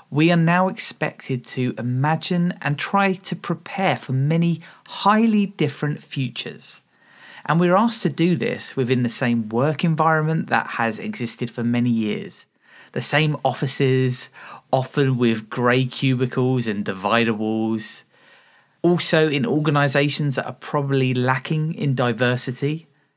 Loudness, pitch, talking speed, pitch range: -21 LUFS, 140 Hz, 130 wpm, 125-165 Hz